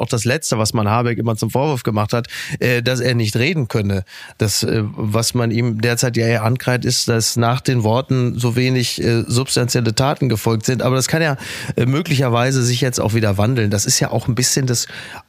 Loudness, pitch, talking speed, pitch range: -17 LUFS, 120 Hz, 205 wpm, 115-130 Hz